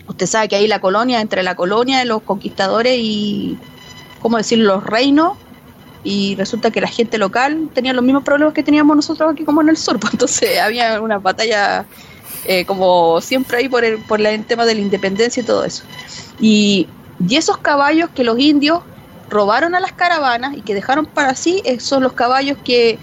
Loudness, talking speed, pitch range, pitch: -15 LUFS, 195 wpm, 210-285 Hz, 235 Hz